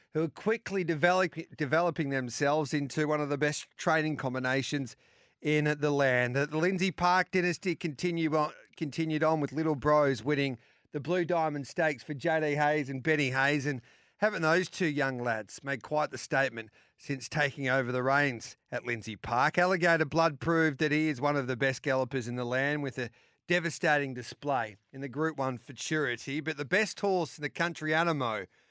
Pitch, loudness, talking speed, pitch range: 150 Hz, -30 LUFS, 180 wpm, 135-160 Hz